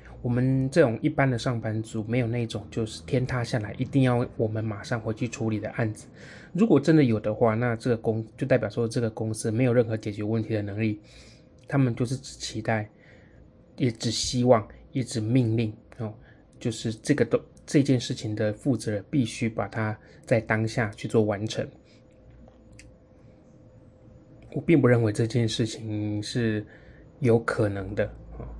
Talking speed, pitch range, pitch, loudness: 250 characters per minute, 110-130 Hz, 115 Hz, -26 LUFS